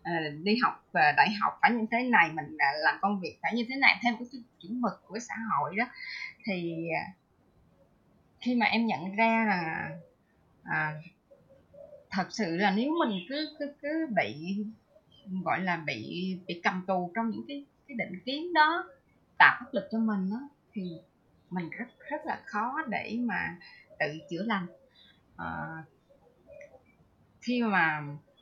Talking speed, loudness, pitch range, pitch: 160 wpm, -29 LUFS, 180-250 Hz, 215 Hz